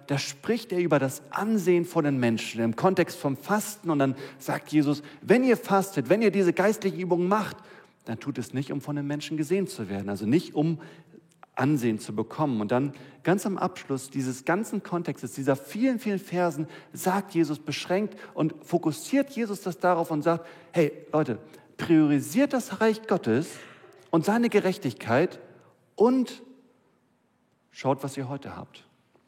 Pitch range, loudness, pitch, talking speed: 140-195 Hz, -27 LUFS, 165 Hz, 165 wpm